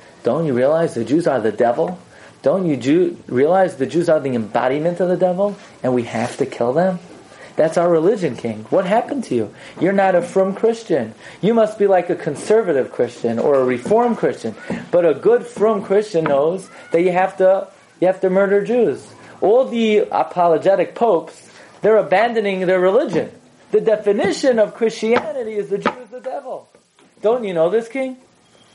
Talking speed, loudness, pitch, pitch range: 185 wpm, -18 LUFS, 195 Hz, 165-225 Hz